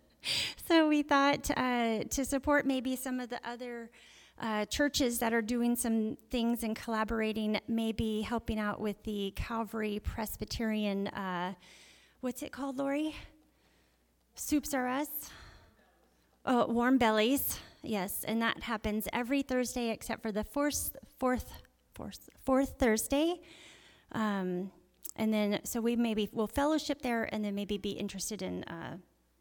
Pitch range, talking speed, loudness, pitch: 215-265 Hz, 140 wpm, -33 LUFS, 230 Hz